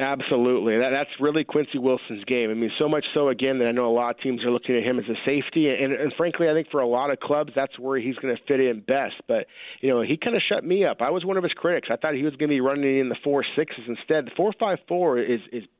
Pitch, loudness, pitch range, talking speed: 135 Hz, -24 LUFS, 125-150 Hz, 305 wpm